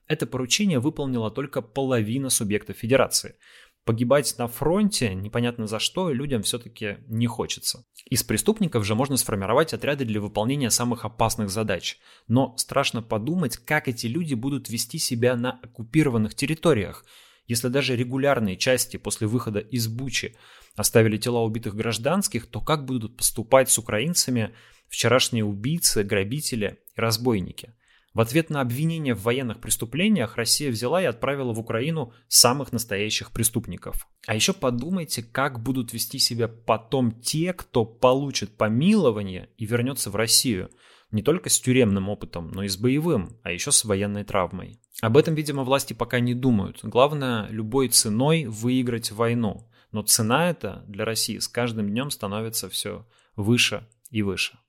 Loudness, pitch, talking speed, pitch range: -24 LUFS, 120 Hz, 145 wpm, 110-135 Hz